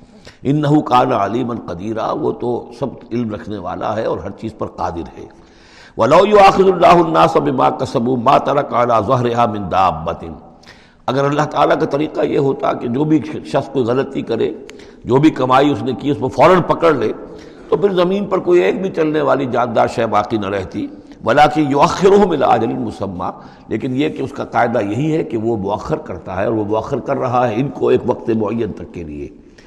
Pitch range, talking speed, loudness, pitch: 105-155 Hz, 200 wpm, -16 LUFS, 125 Hz